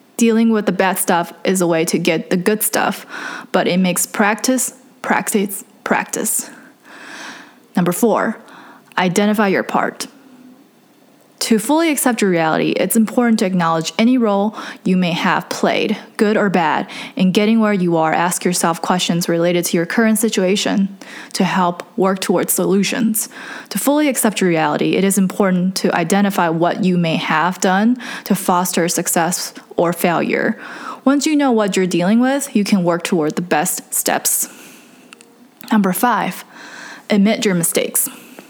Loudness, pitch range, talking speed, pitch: -16 LUFS, 185-245 Hz, 155 wpm, 210 Hz